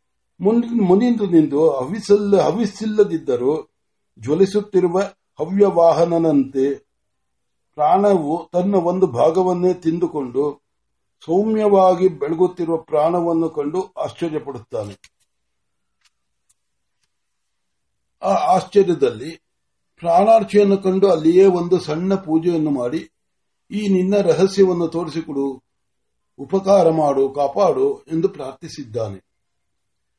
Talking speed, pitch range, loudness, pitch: 60 wpm, 145-200 Hz, -18 LUFS, 175 Hz